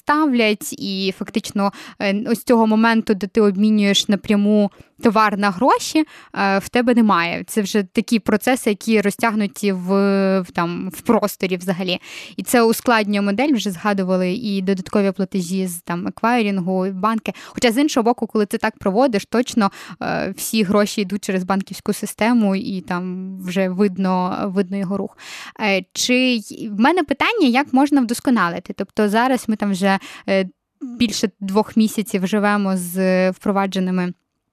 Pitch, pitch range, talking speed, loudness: 210 Hz, 195-230 Hz, 140 wpm, -19 LUFS